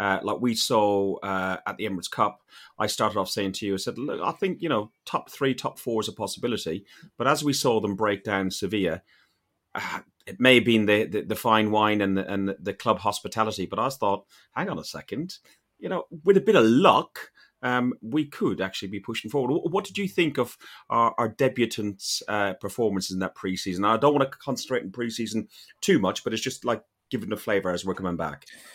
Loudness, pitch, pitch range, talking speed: -26 LUFS, 110 Hz, 100-125 Hz, 225 wpm